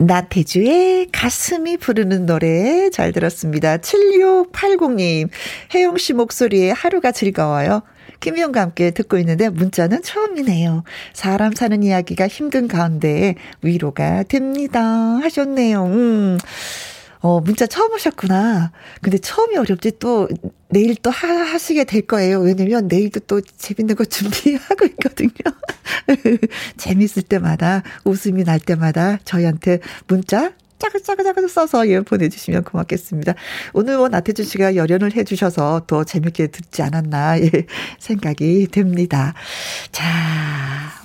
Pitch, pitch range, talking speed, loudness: 200 Hz, 175-250 Hz, 285 characters per minute, -17 LUFS